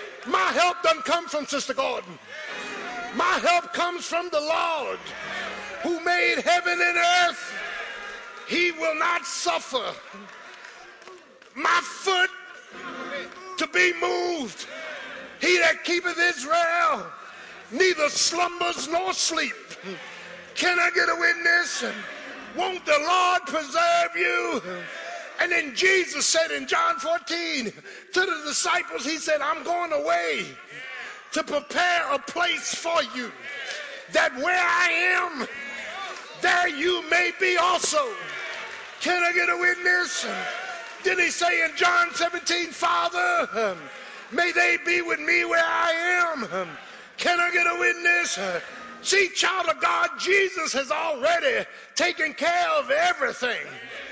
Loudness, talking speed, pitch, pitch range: -23 LUFS, 125 wpm, 345 Hz, 325-355 Hz